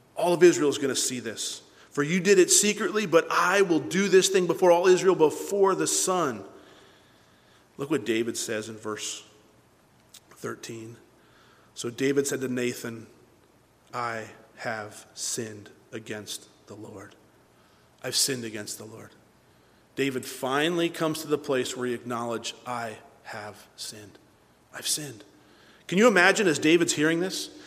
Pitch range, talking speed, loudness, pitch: 115-175 Hz, 150 wpm, -25 LUFS, 135 Hz